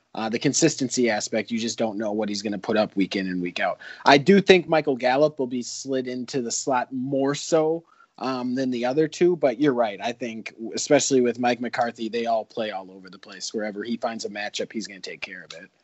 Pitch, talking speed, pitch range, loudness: 125 Hz, 245 wpm, 110-140 Hz, -24 LUFS